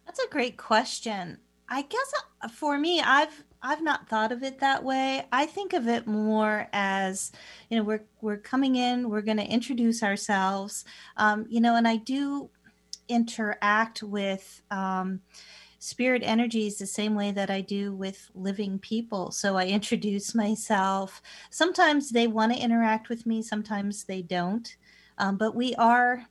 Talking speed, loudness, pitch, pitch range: 160 wpm, -27 LUFS, 220 Hz, 200-240 Hz